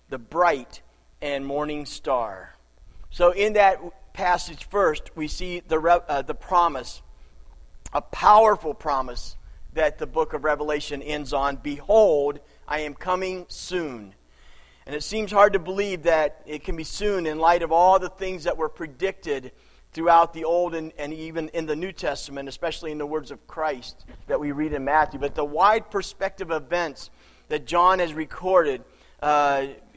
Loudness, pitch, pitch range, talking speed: -24 LUFS, 155 Hz, 145-180 Hz, 165 wpm